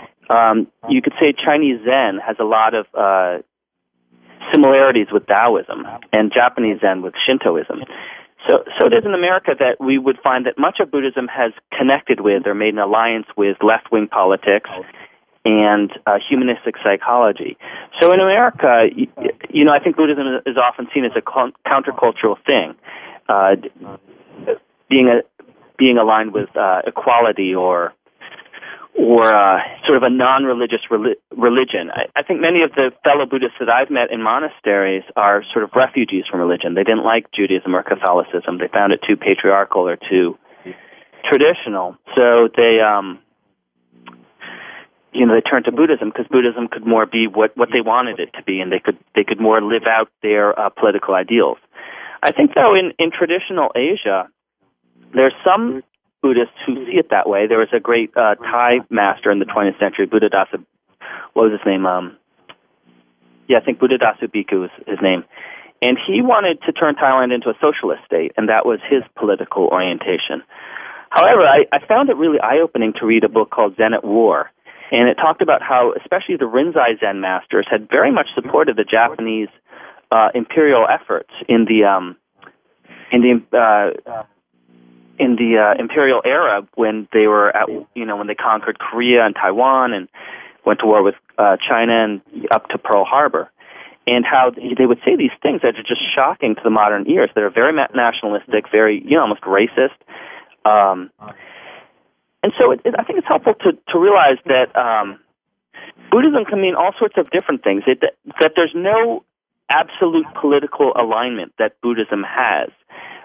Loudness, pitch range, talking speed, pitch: -15 LUFS, 100-135 Hz, 175 wpm, 115 Hz